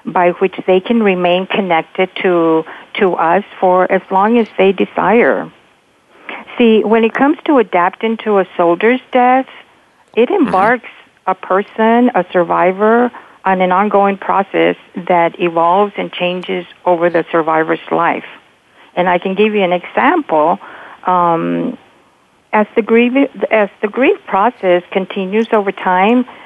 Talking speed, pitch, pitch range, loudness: 140 wpm, 195 Hz, 180-225 Hz, -13 LUFS